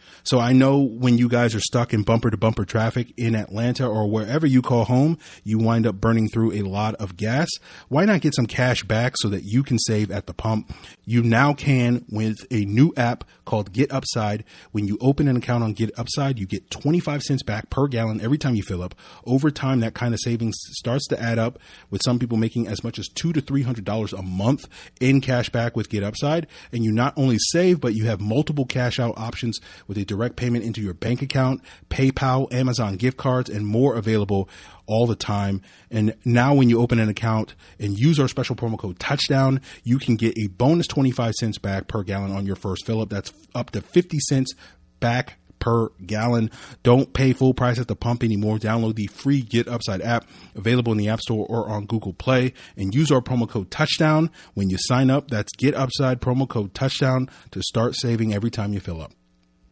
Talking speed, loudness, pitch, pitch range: 215 wpm, -22 LUFS, 115 Hz, 105-130 Hz